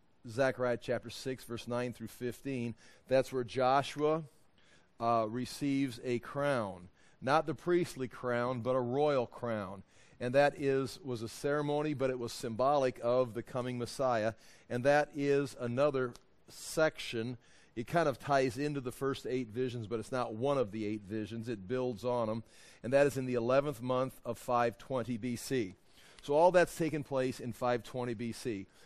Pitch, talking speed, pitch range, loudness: 125 Hz, 165 wpm, 120-140 Hz, -34 LUFS